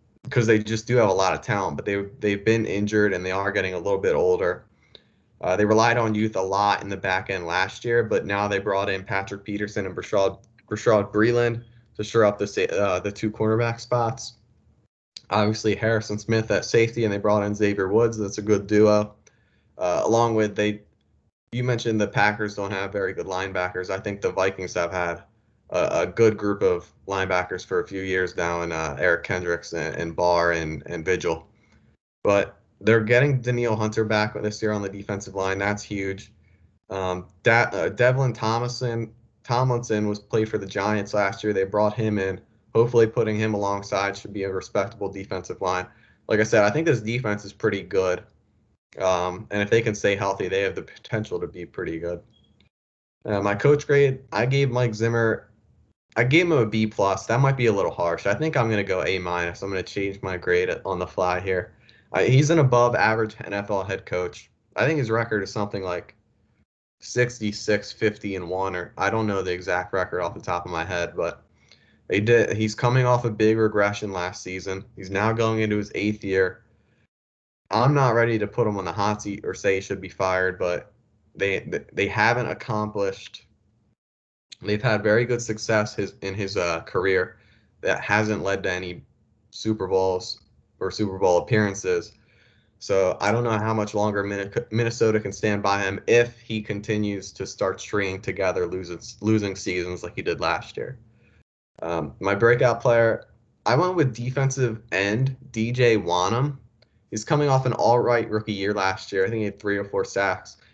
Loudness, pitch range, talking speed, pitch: -24 LUFS, 95-115 Hz, 195 wpm, 105 Hz